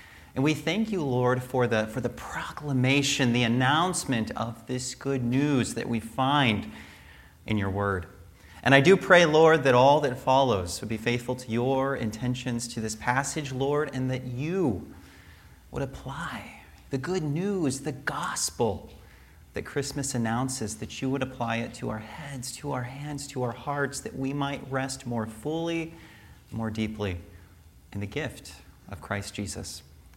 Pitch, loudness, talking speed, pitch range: 125 Hz, -27 LUFS, 165 wpm, 110-140 Hz